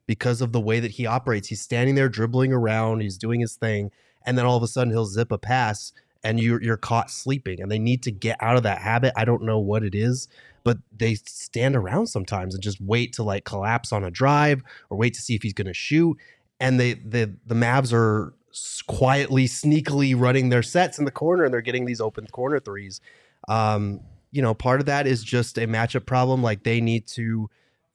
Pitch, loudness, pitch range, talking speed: 115 Hz, -23 LUFS, 110-130 Hz, 225 wpm